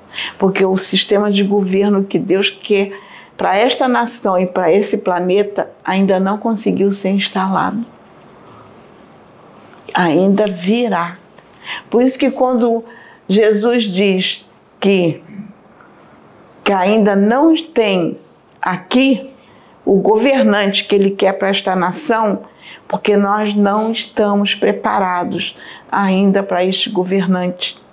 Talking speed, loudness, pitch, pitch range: 110 wpm, -15 LUFS, 200 Hz, 190-220 Hz